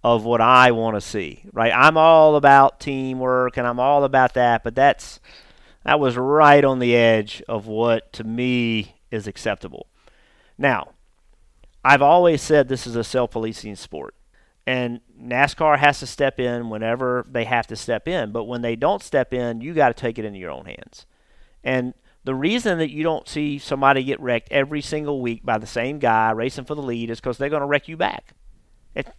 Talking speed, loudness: 195 wpm, -19 LUFS